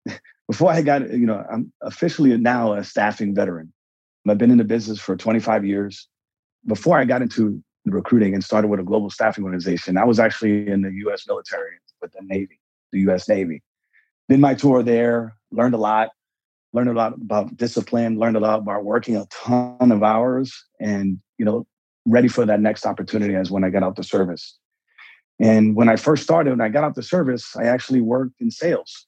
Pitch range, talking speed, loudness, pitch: 105-125 Hz, 200 wpm, -20 LUFS, 115 Hz